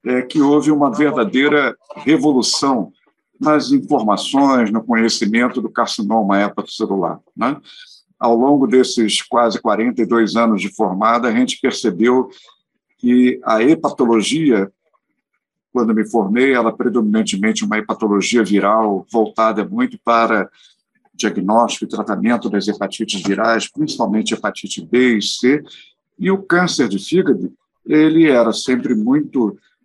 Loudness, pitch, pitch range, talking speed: -16 LUFS, 120 Hz, 110-150 Hz, 125 wpm